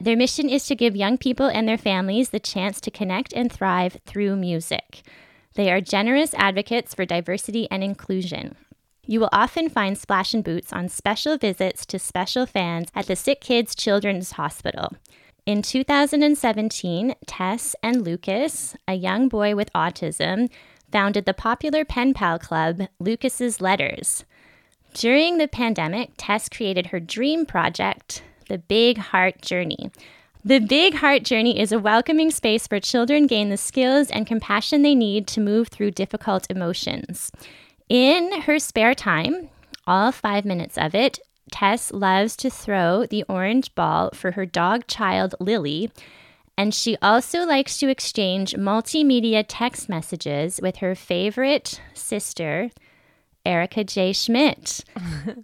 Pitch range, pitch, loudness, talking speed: 190-255 Hz, 215 Hz, -22 LUFS, 145 wpm